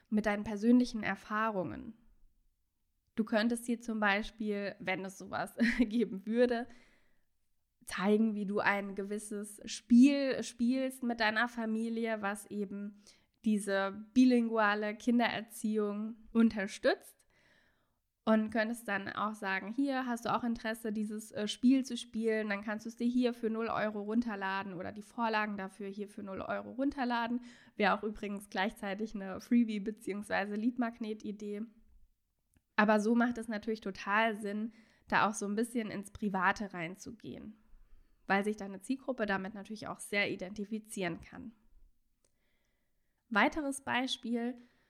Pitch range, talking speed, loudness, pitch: 205-235 Hz, 130 wpm, -34 LUFS, 215 Hz